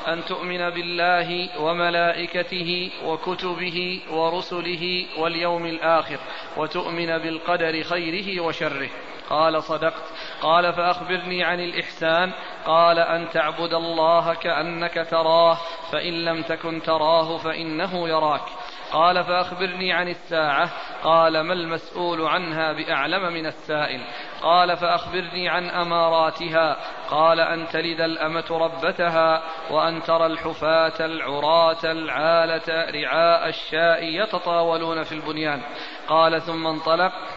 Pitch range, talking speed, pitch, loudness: 160-175 Hz, 100 wpm, 165 Hz, -22 LUFS